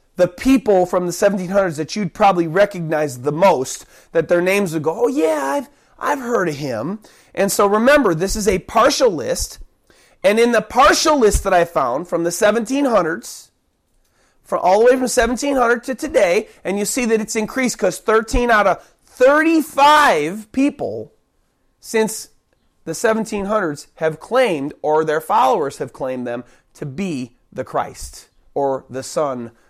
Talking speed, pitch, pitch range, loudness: 165 wpm, 205 Hz, 165-240 Hz, -17 LUFS